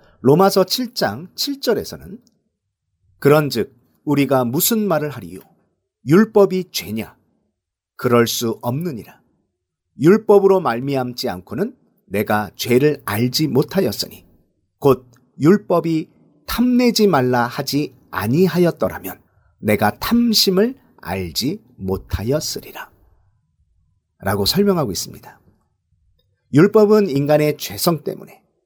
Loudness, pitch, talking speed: -18 LUFS, 135 Hz, 225 characters per minute